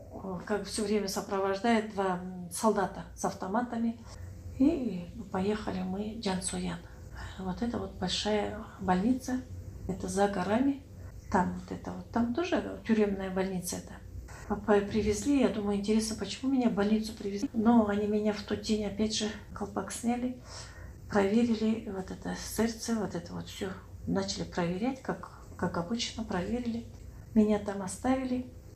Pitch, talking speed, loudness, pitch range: 205 Hz, 140 wpm, -32 LUFS, 180-225 Hz